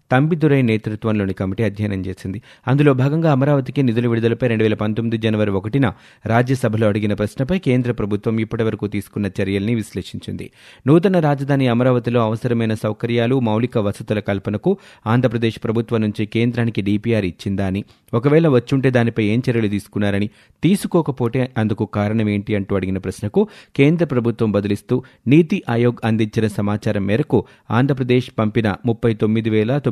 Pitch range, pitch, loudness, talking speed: 105-130 Hz, 115 Hz, -19 LUFS, 125 wpm